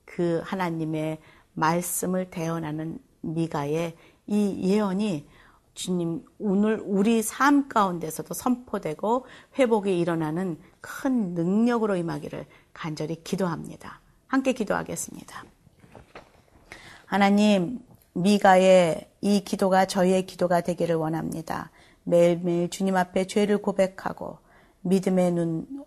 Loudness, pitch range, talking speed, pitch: -25 LUFS, 165-205 Hz, 255 characters per minute, 185 Hz